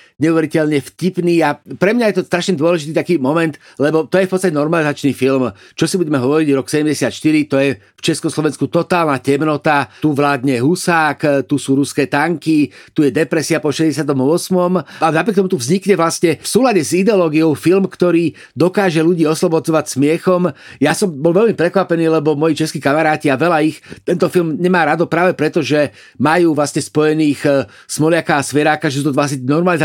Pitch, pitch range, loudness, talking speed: 155 Hz, 145-170 Hz, -15 LUFS, 175 wpm